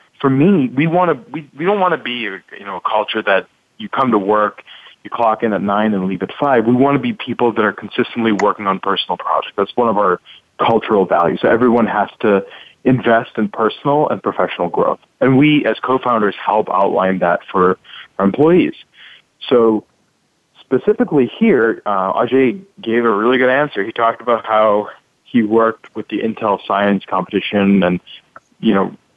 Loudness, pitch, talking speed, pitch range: -15 LUFS, 115 Hz, 185 wpm, 105-130 Hz